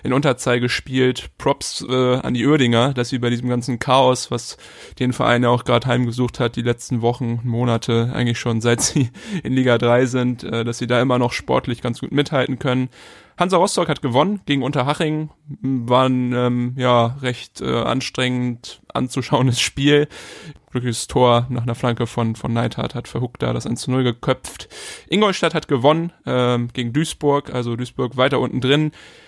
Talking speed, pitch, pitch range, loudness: 170 wpm, 125 Hz, 120-135 Hz, -19 LUFS